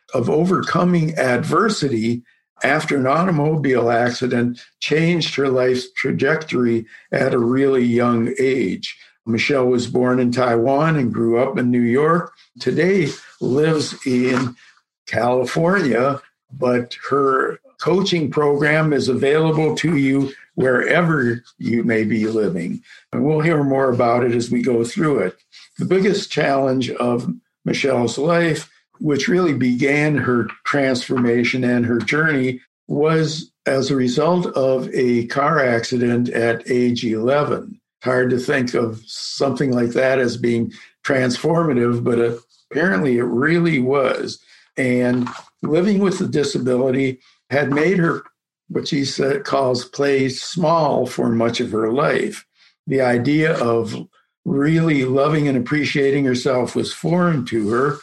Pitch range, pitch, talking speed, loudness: 120-150 Hz, 130 Hz, 130 wpm, -18 LUFS